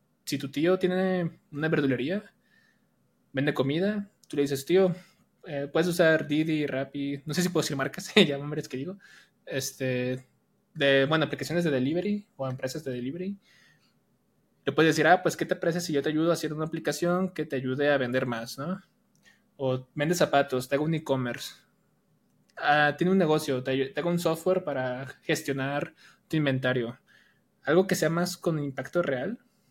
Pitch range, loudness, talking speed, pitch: 135-180 Hz, -28 LUFS, 180 wpm, 155 Hz